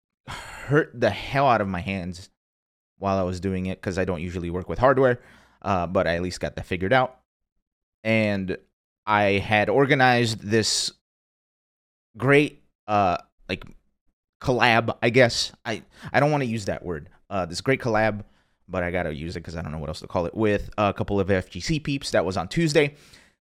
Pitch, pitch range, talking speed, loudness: 100 Hz, 90-120 Hz, 190 wpm, -24 LUFS